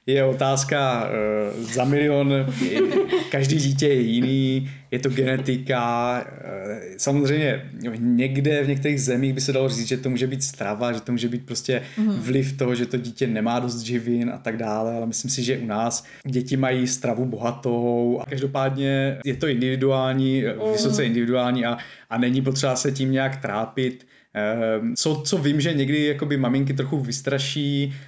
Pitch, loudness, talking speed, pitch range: 130 Hz, -23 LUFS, 160 wpm, 120-140 Hz